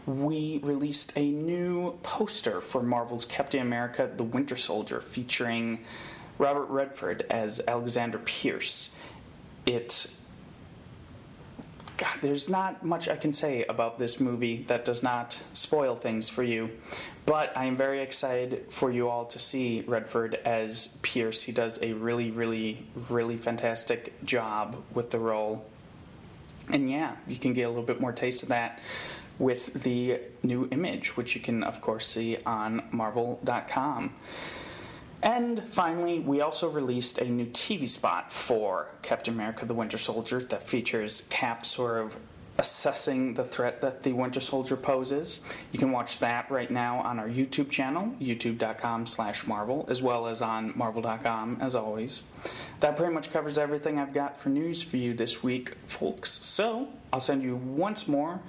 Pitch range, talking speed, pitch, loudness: 115-140 Hz, 155 wpm, 125 Hz, -30 LUFS